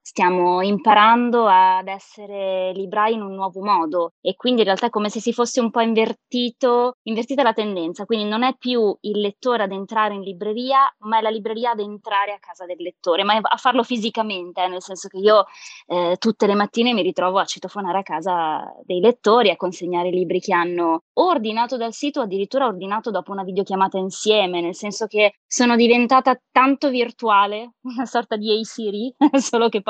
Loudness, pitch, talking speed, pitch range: -19 LUFS, 215 Hz, 195 wpm, 190-235 Hz